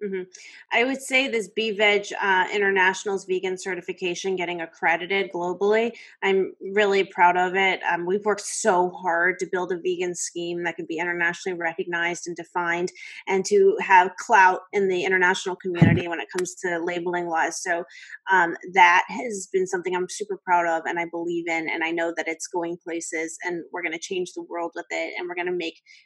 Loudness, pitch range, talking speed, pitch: -23 LUFS, 170-195 Hz, 195 wpm, 180 Hz